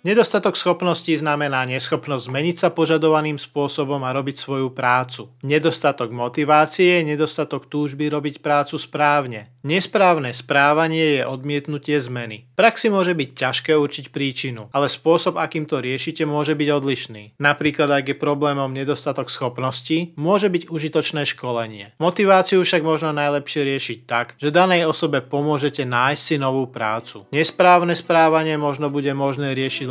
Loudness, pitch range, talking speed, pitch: -19 LUFS, 135-160 Hz, 140 wpm, 145 Hz